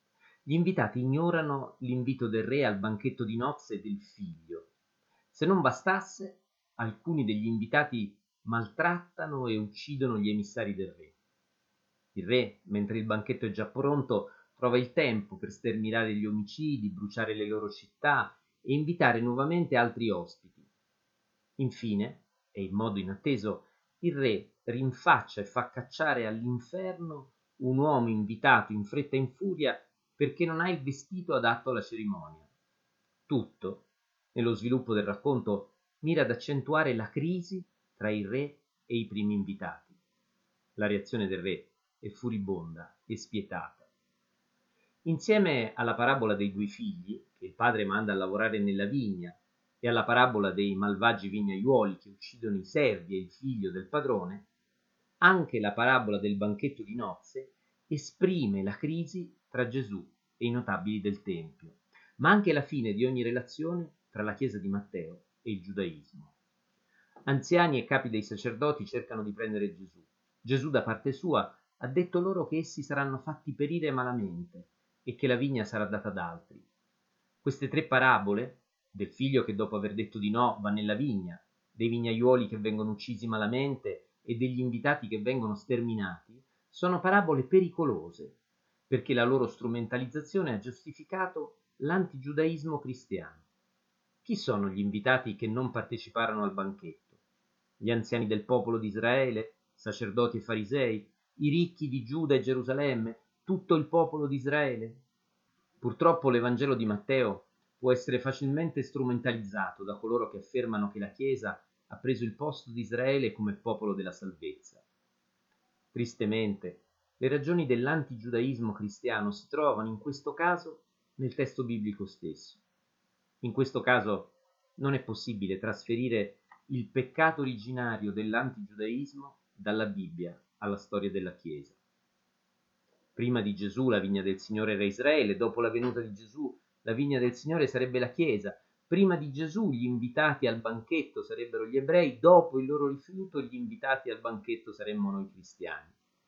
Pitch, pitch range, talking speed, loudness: 125 Hz, 110-155 Hz, 145 wpm, -31 LUFS